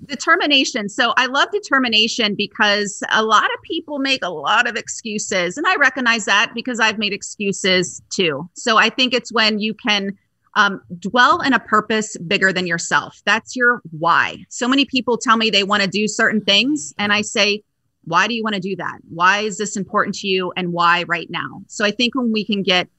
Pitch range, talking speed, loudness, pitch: 195-240 Hz, 210 wpm, -17 LUFS, 215 Hz